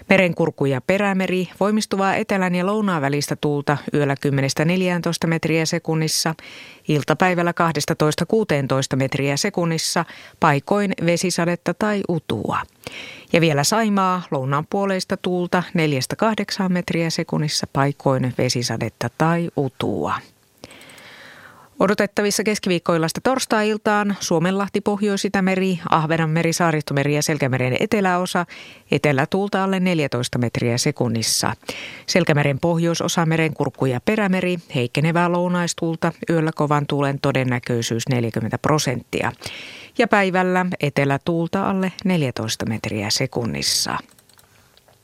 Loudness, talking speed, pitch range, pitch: -20 LUFS, 95 wpm, 140-185 Hz, 165 Hz